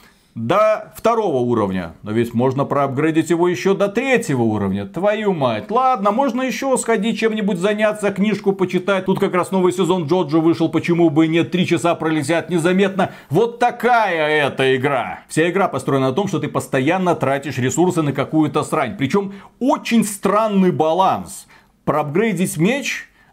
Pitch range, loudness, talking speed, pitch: 150-205 Hz, -18 LUFS, 155 wpm, 180 Hz